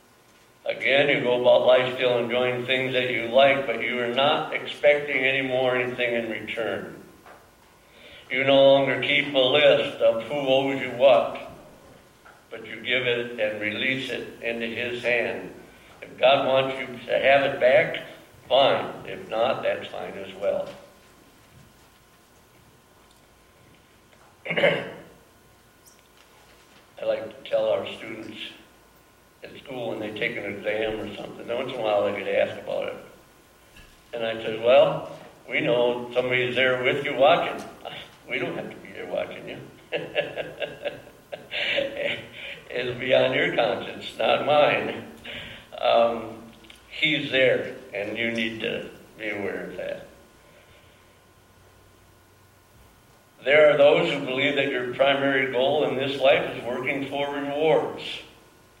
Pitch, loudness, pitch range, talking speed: 125 Hz, -23 LUFS, 115-135 Hz, 135 wpm